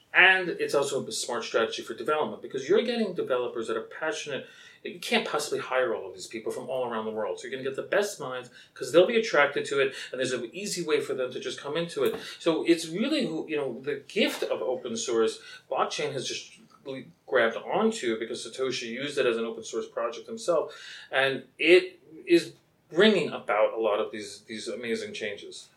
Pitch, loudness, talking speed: 380 Hz, -28 LUFS, 215 wpm